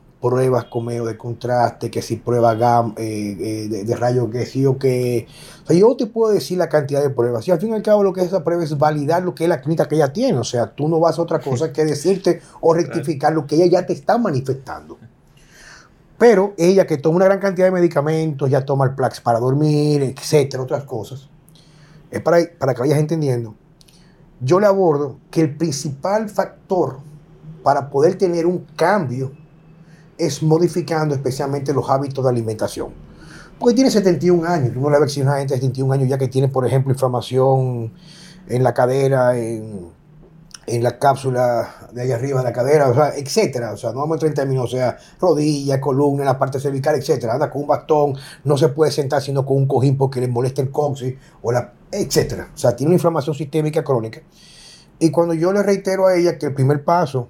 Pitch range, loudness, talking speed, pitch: 130-165 Hz, -18 LUFS, 210 wpm, 145 Hz